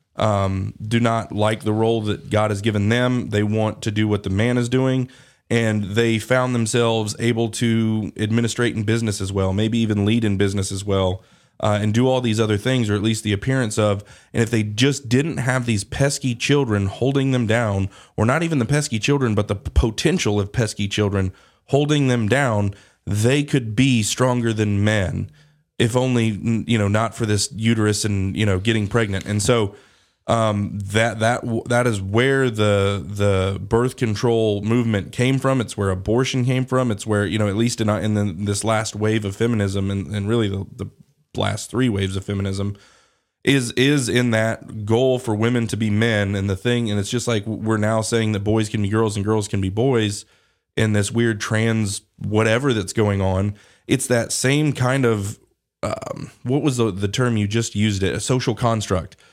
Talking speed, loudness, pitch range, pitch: 200 wpm, -20 LUFS, 105-120 Hz, 110 Hz